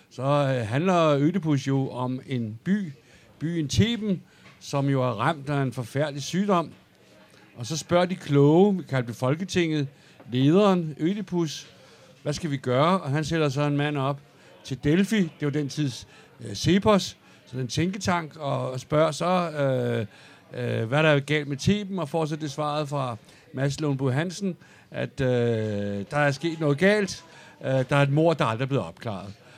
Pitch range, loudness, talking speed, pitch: 130-165 Hz, -25 LUFS, 180 wpm, 145 Hz